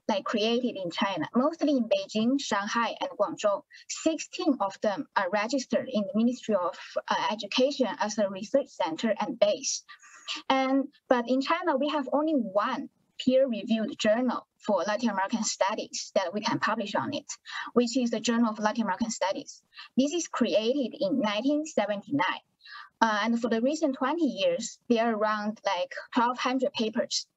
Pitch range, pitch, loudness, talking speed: 220-295 Hz, 255 Hz, -28 LUFS, 160 wpm